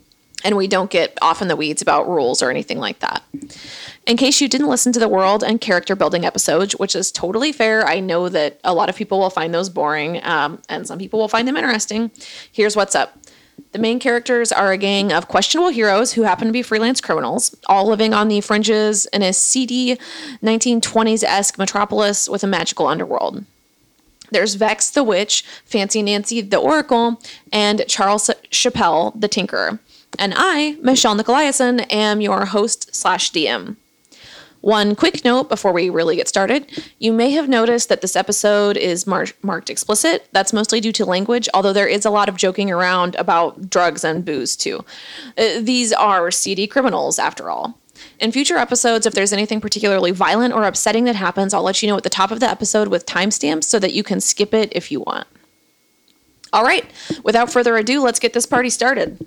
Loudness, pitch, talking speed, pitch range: -17 LUFS, 215 Hz, 190 wpm, 195-240 Hz